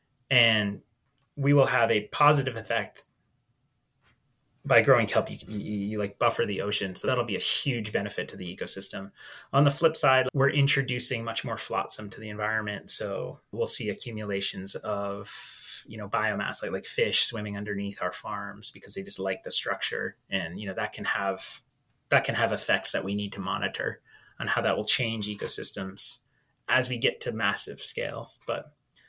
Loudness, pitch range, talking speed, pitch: -26 LUFS, 100-130 Hz, 180 wpm, 115 Hz